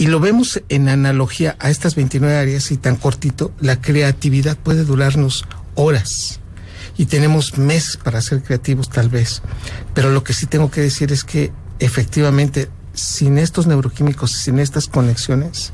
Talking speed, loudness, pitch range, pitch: 155 wpm, -16 LUFS, 120-150 Hz, 135 Hz